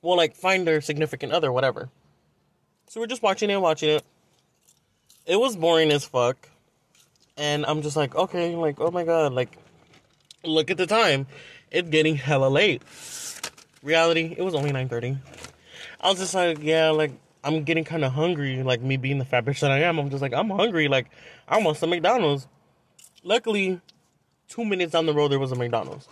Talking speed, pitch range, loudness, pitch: 190 wpm, 140-175 Hz, -23 LUFS, 155 Hz